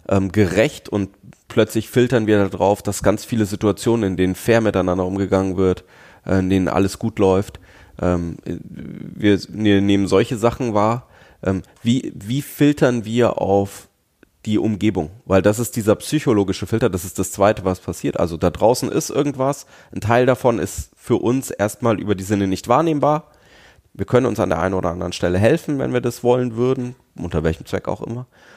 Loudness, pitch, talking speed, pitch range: -19 LUFS, 105 Hz, 170 wpm, 95-120 Hz